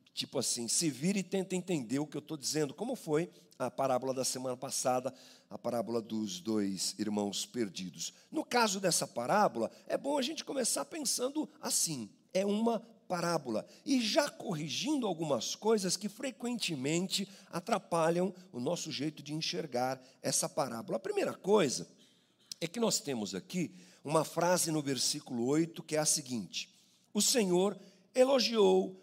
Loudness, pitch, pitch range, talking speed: -33 LUFS, 170 Hz, 135-205 Hz, 155 wpm